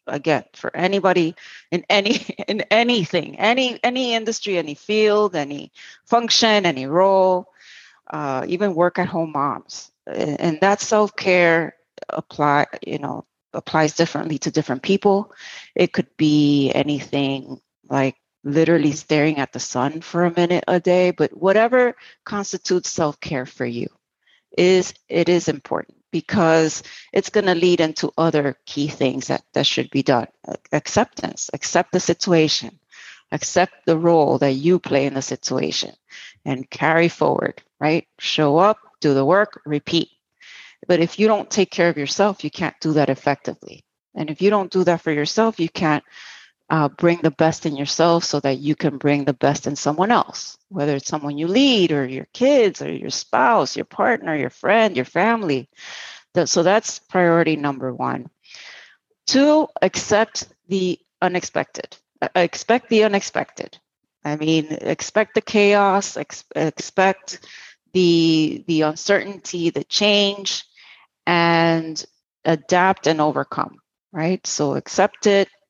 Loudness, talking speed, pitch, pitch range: -19 LUFS, 145 wpm, 170 Hz, 150-195 Hz